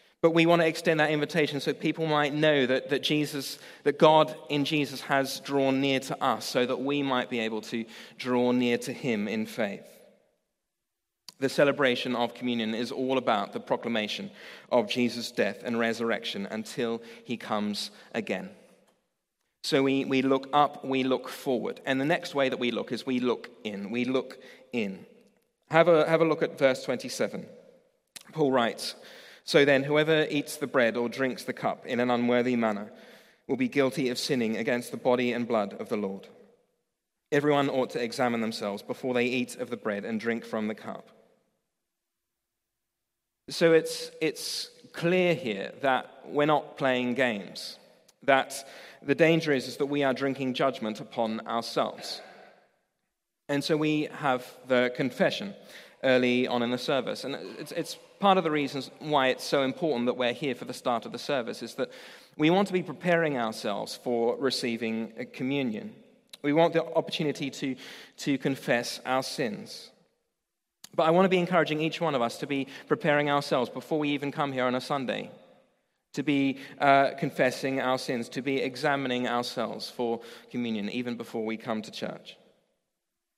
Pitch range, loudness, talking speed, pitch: 120-150 Hz, -28 LUFS, 175 wpm, 135 Hz